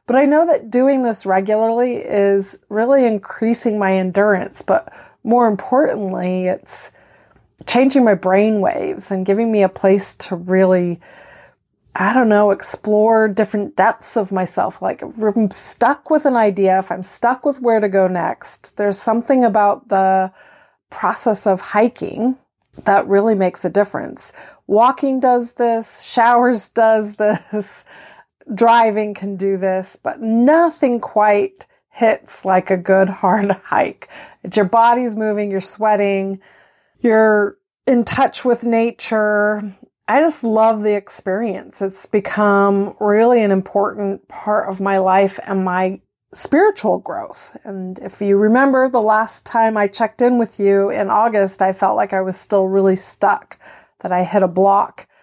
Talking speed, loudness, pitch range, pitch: 150 wpm, -16 LUFS, 195-235 Hz, 210 Hz